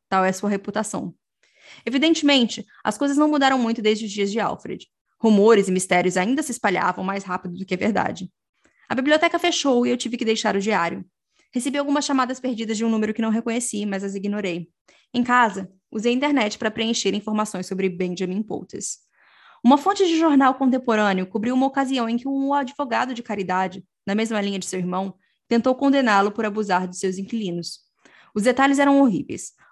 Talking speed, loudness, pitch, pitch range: 190 wpm, -21 LUFS, 225 Hz, 195-260 Hz